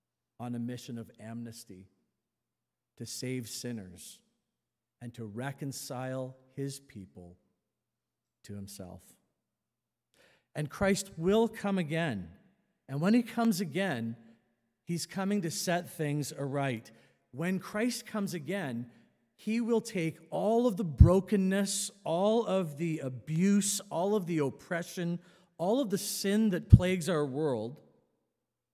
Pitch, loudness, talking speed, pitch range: 160 Hz, -31 LUFS, 120 wpm, 120-195 Hz